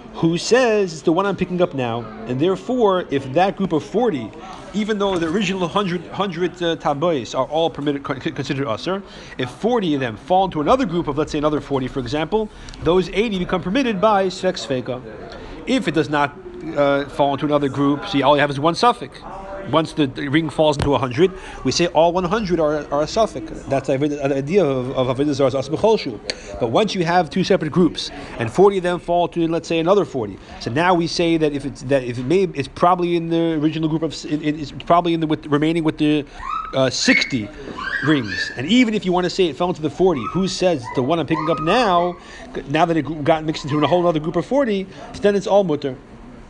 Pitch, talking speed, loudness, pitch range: 165 Hz, 225 wpm, -19 LUFS, 145-185 Hz